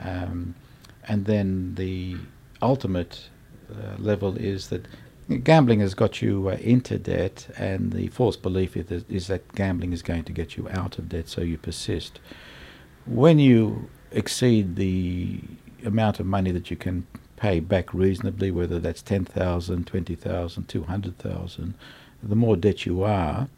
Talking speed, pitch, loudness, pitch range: 145 wpm, 95 Hz, -25 LUFS, 90-110 Hz